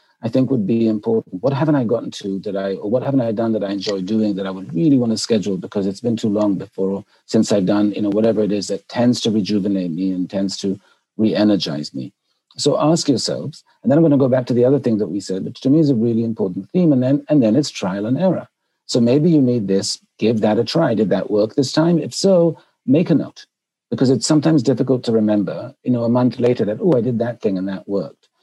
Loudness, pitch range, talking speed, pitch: -18 LUFS, 100-135 Hz, 260 wpm, 115 Hz